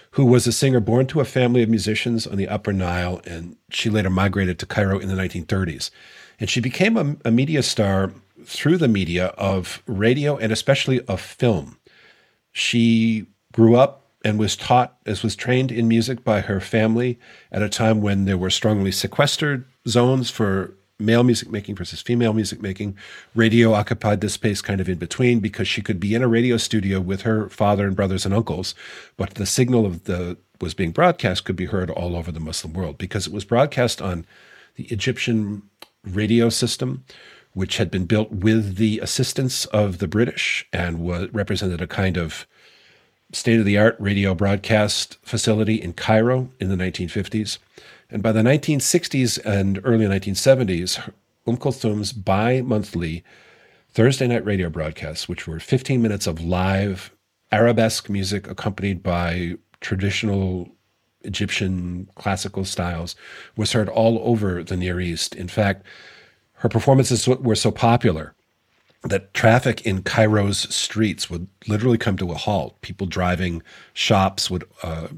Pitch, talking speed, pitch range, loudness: 105 Hz, 160 wpm, 95-115 Hz, -21 LUFS